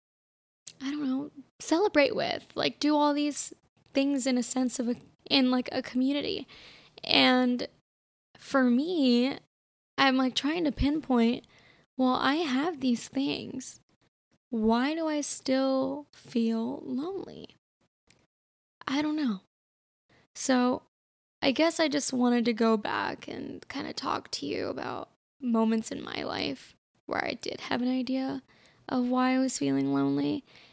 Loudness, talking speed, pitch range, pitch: -28 LUFS, 145 wpm, 245-285 Hz, 260 Hz